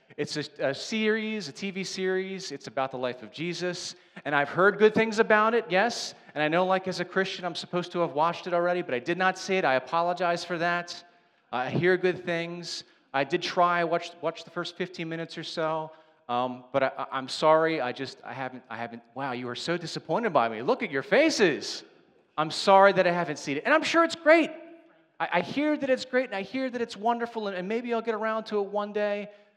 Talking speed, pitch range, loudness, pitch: 235 wpm, 155-210 Hz, -27 LUFS, 175 Hz